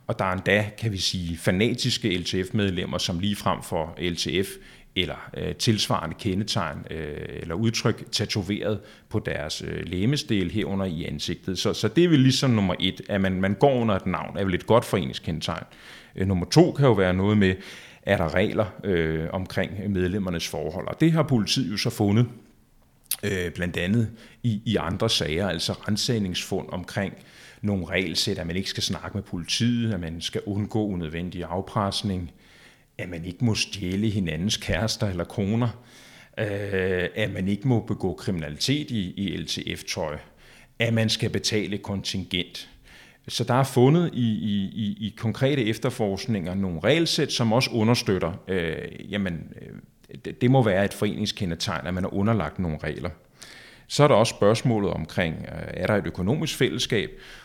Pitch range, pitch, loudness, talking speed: 90-115 Hz, 105 Hz, -25 LUFS, 165 wpm